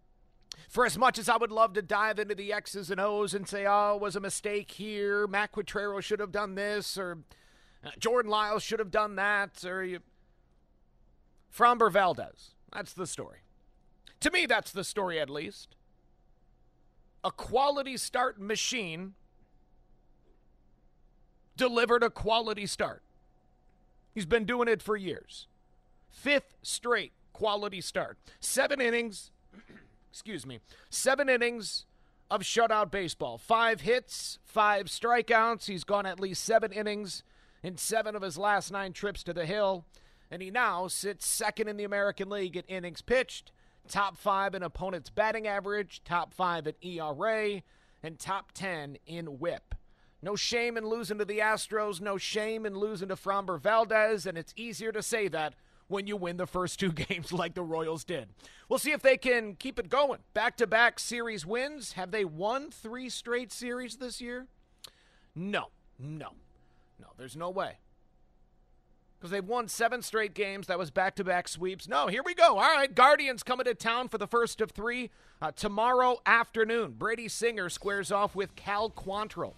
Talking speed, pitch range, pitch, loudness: 165 wpm, 185-230 Hz, 205 Hz, -30 LUFS